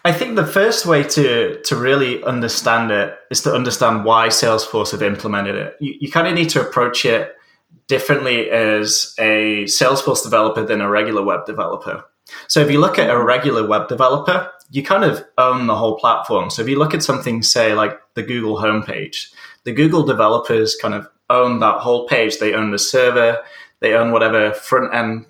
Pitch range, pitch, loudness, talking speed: 110-145 Hz, 125 Hz, -16 LUFS, 190 wpm